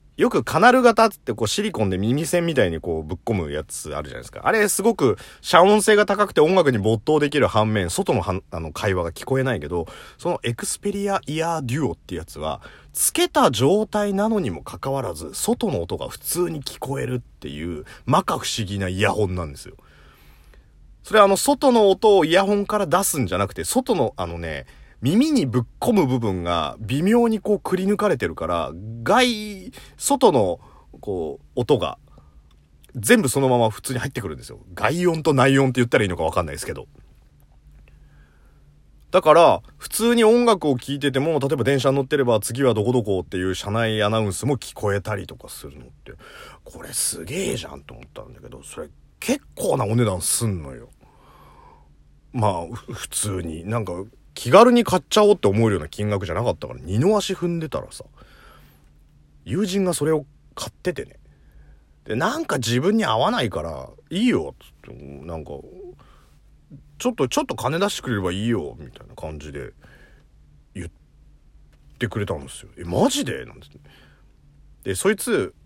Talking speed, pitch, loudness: 335 characters per minute, 125 Hz, -21 LUFS